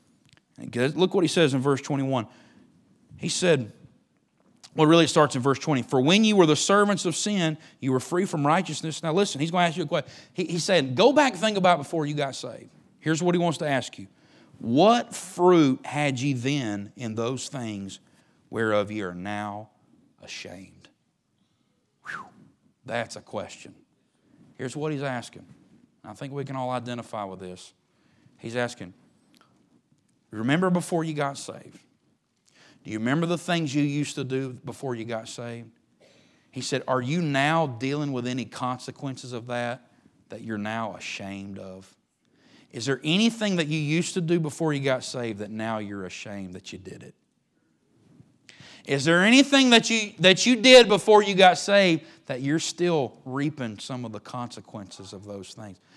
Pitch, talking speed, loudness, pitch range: 140 Hz, 175 wpm, -24 LUFS, 120-170 Hz